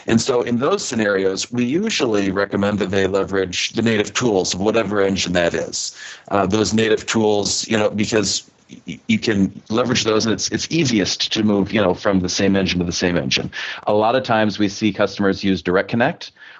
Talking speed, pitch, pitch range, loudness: 205 wpm, 100 Hz, 95-110 Hz, -19 LUFS